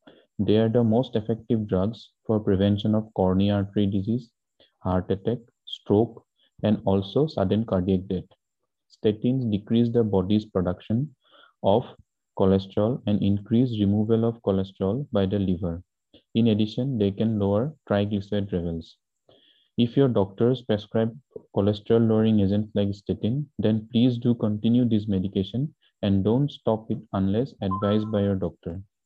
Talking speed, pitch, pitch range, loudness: 135 wpm, 105 Hz, 100-115 Hz, -25 LUFS